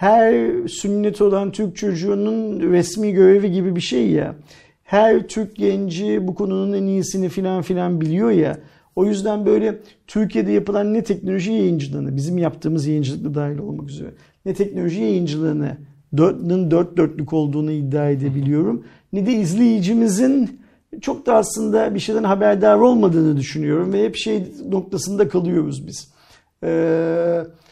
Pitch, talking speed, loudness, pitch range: 190 Hz, 135 wpm, -19 LUFS, 165-210 Hz